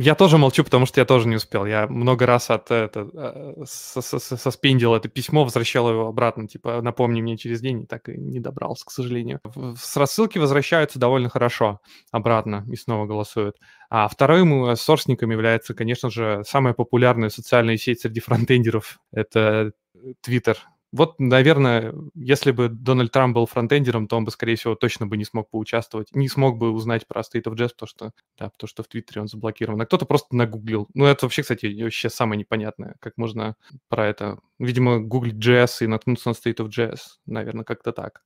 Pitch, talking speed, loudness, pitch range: 120 Hz, 185 wpm, -21 LUFS, 110-130 Hz